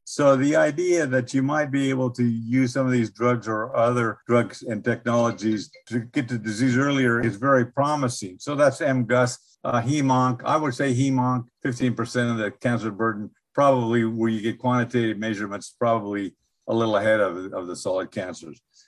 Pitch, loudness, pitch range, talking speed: 120 Hz, -23 LUFS, 115-130 Hz, 180 wpm